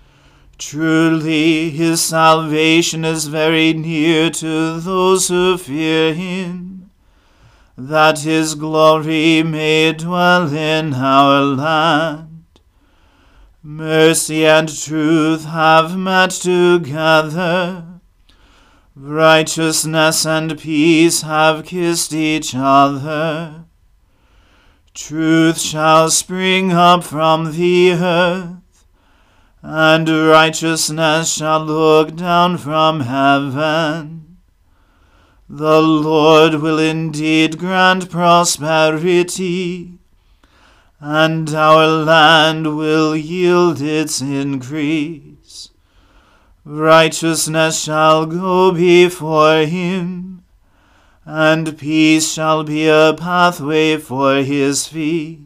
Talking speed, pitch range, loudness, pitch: 80 wpm, 155-165 Hz, -13 LUFS, 160 Hz